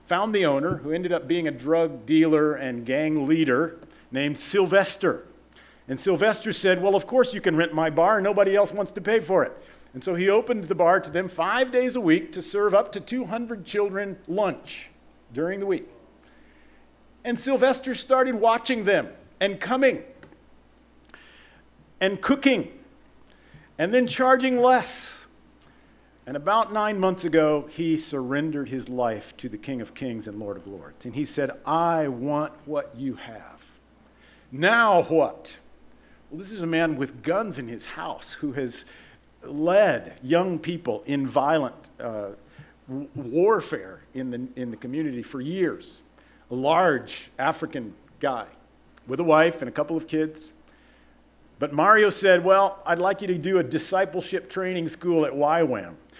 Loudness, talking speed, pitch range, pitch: -24 LUFS, 160 wpm, 150-205 Hz, 175 Hz